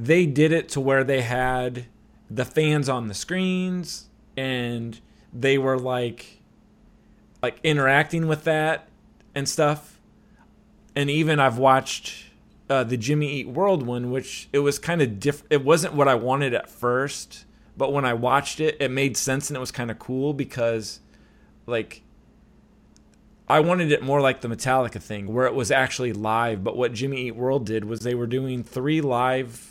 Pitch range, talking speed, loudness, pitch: 125-145 Hz, 175 wpm, -23 LUFS, 135 Hz